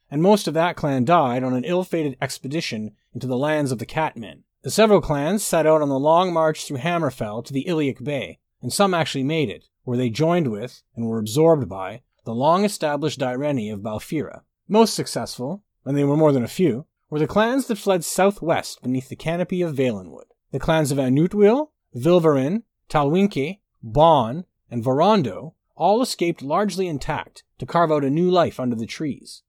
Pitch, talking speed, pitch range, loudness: 150 Hz, 185 wpm, 130-175 Hz, -21 LUFS